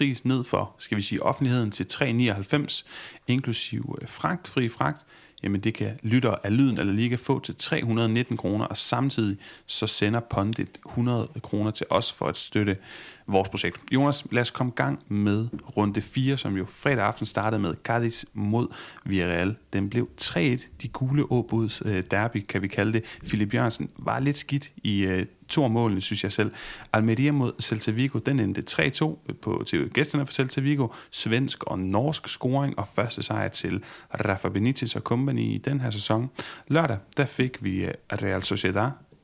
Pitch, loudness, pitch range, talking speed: 115 Hz, -26 LUFS, 105-130 Hz, 175 wpm